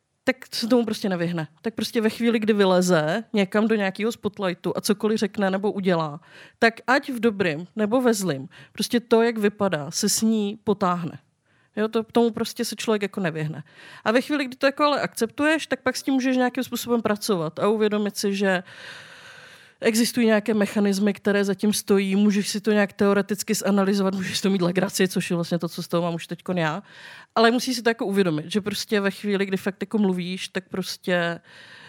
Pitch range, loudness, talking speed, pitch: 185-230 Hz, -23 LUFS, 200 wpm, 205 Hz